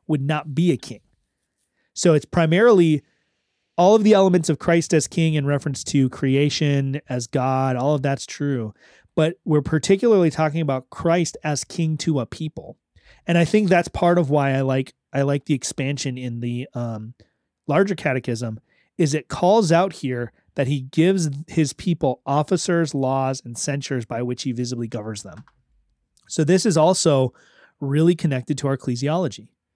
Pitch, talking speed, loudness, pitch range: 145 Hz, 170 wpm, -21 LUFS, 130-170 Hz